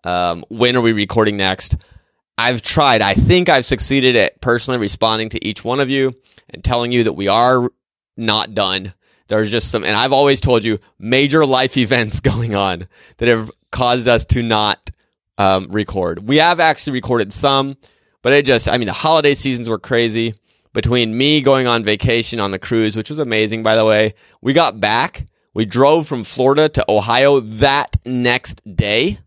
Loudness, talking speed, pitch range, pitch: -15 LUFS, 185 wpm, 110-130 Hz, 115 Hz